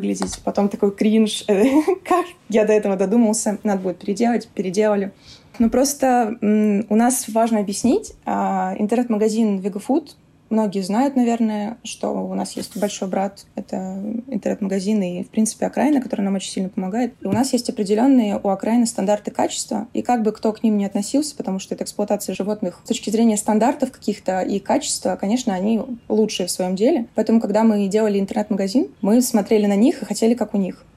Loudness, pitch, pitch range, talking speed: -20 LUFS, 215 Hz, 200-235 Hz, 180 wpm